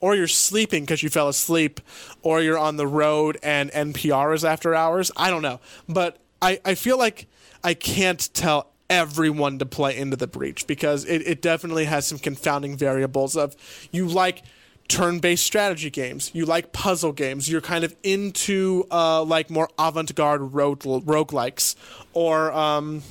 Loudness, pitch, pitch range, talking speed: -22 LUFS, 155 Hz, 145-170 Hz, 165 wpm